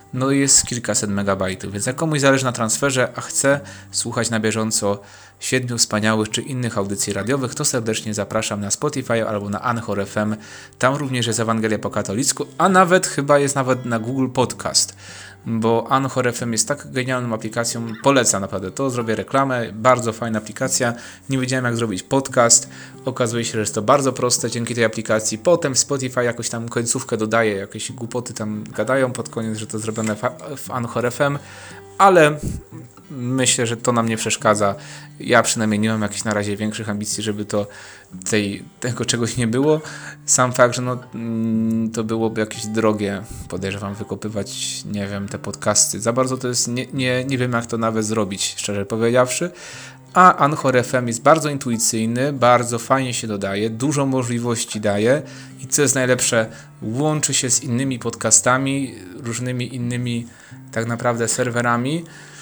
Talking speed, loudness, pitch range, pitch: 165 wpm, -19 LUFS, 110-130 Hz, 115 Hz